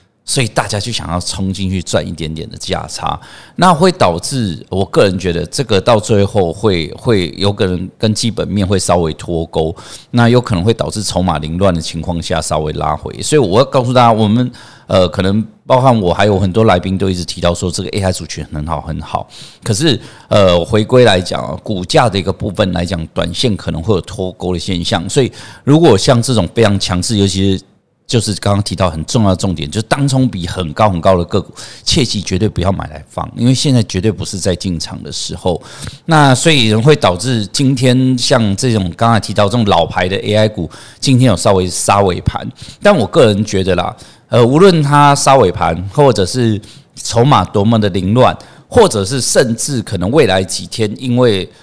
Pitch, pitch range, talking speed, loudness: 100 Hz, 90-120 Hz, 300 characters per minute, -13 LUFS